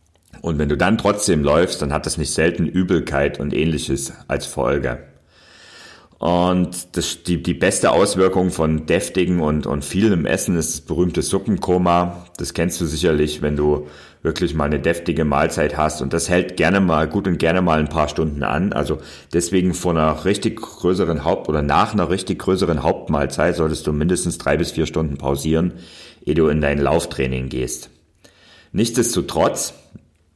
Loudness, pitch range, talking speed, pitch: -19 LUFS, 75-90 Hz, 165 wpm, 80 Hz